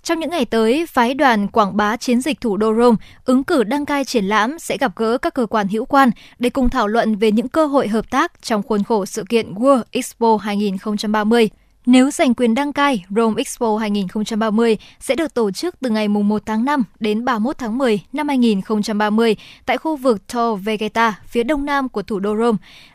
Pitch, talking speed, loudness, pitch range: 230 Hz, 210 wpm, -18 LUFS, 215-260 Hz